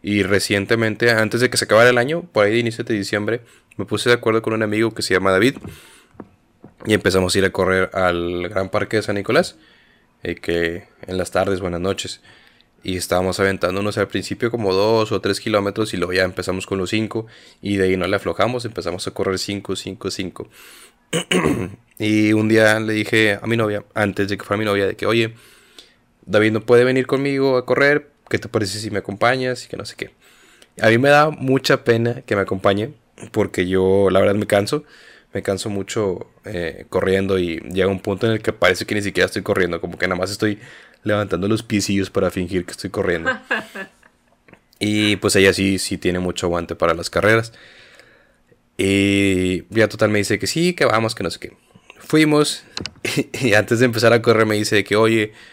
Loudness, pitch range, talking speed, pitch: -19 LUFS, 95-115 Hz, 205 wpm, 105 Hz